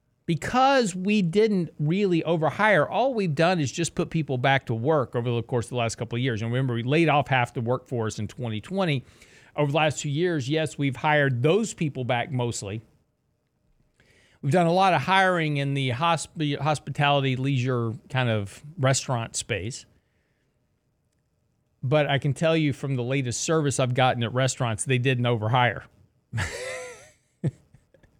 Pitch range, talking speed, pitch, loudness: 120-160 Hz, 165 wpm, 140 Hz, -25 LUFS